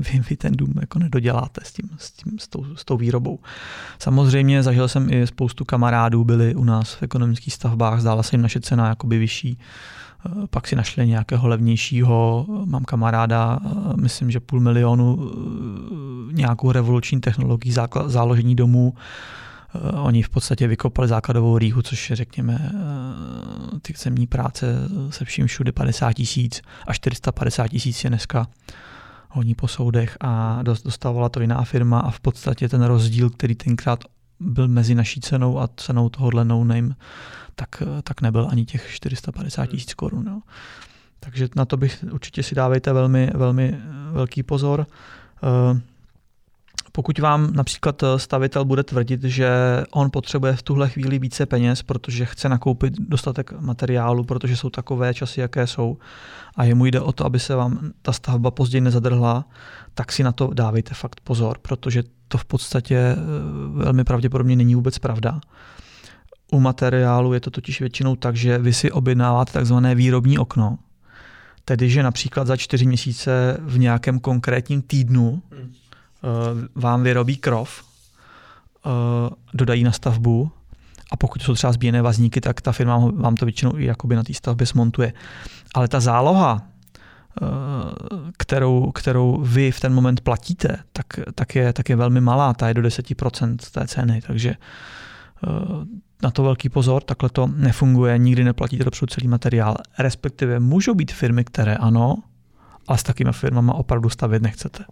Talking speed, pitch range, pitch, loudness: 150 wpm, 120-135 Hz, 125 Hz, -20 LUFS